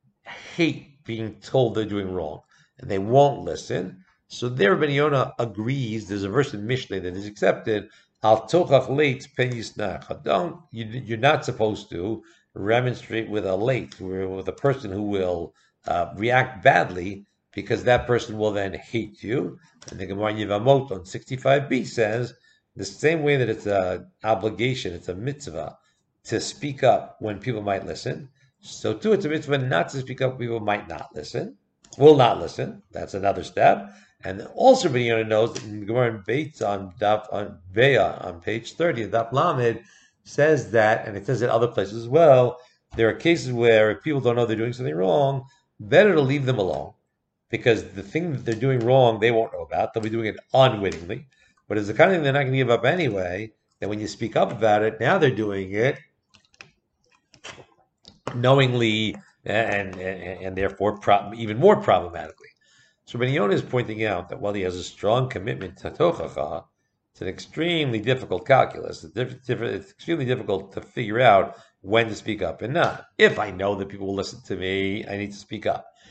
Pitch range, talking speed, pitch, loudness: 100-130 Hz, 180 wpm, 115 Hz, -23 LUFS